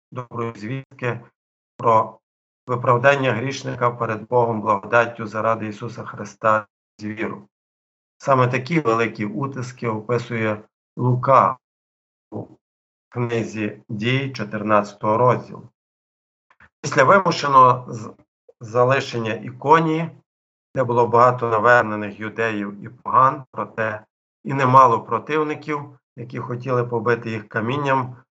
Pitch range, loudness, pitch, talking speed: 110-125 Hz, -20 LUFS, 115 Hz, 95 wpm